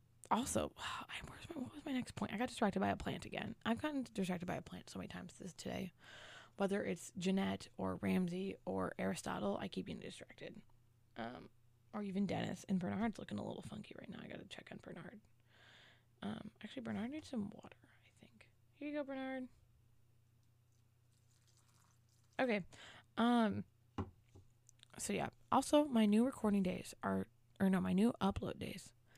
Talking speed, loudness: 170 wpm, -41 LUFS